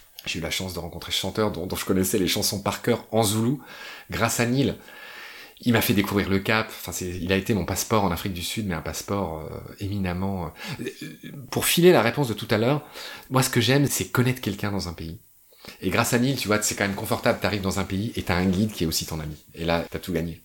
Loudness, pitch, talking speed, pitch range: -24 LUFS, 100 Hz, 275 wpm, 90-115 Hz